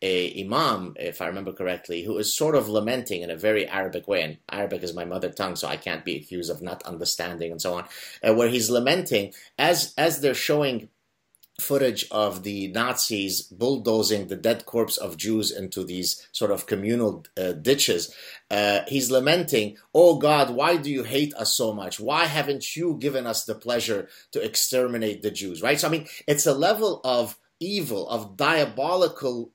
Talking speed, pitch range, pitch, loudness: 185 wpm, 100-140 Hz, 115 Hz, -24 LUFS